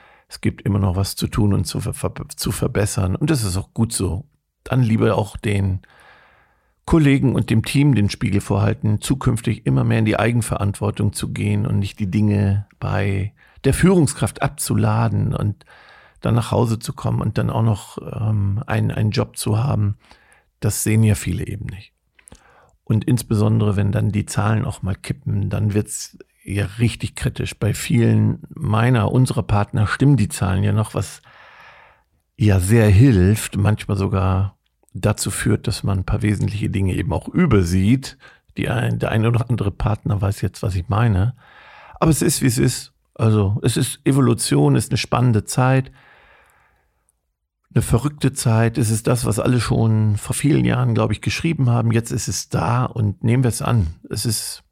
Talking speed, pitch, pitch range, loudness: 180 wpm, 110 Hz, 105-125 Hz, -19 LUFS